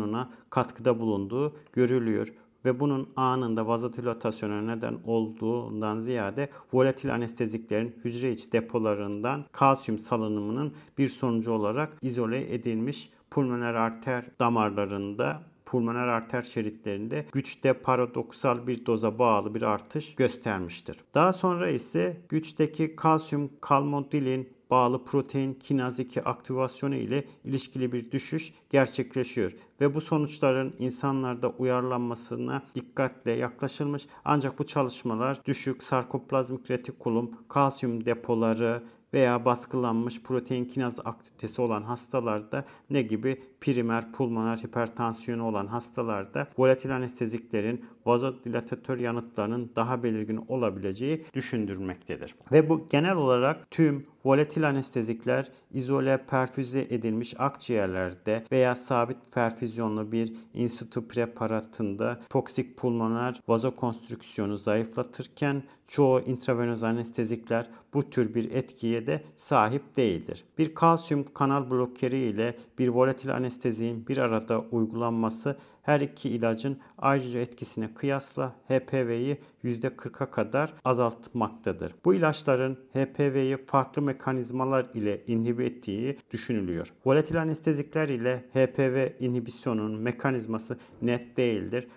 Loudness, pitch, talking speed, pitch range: -29 LUFS, 125 Hz, 105 wpm, 115-135 Hz